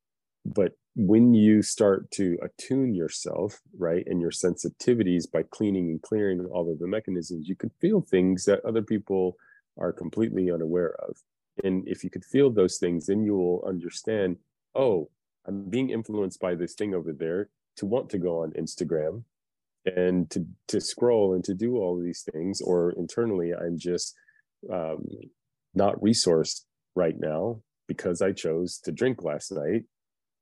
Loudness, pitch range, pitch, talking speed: -27 LUFS, 90-105 Hz, 95 Hz, 165 wpm